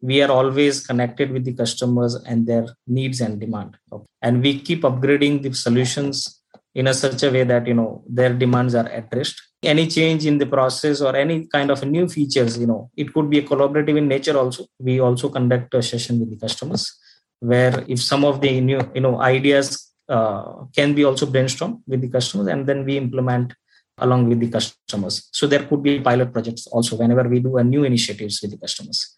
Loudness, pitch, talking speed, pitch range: -19 LUFS, 130 Hz, 205 wpm, 120-140 Hz